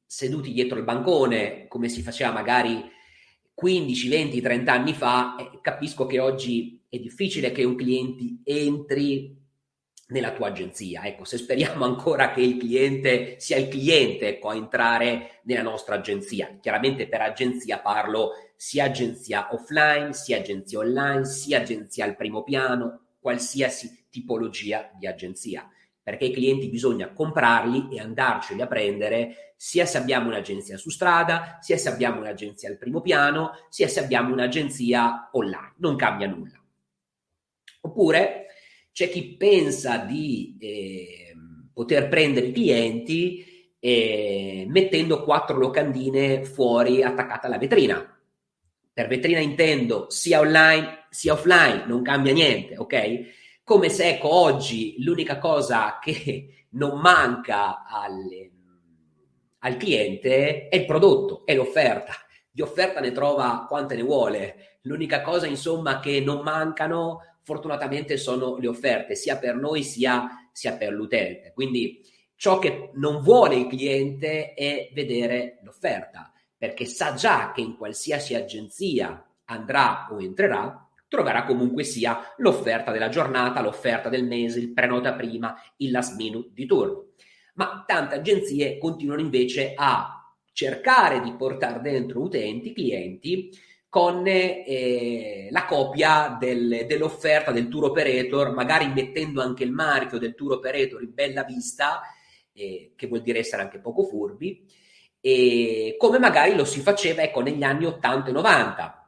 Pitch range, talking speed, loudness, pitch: 120-155 Hz, 140 wpm, -23 LUFS, 135 Hz